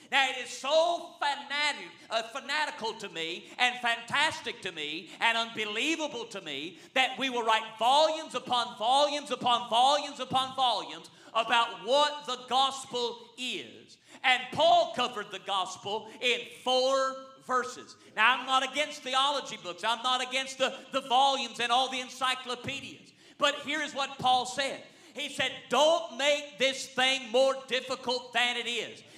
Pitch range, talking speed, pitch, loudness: 240-280 Hz, 150 wpm, 255 Hz, -29 LUFS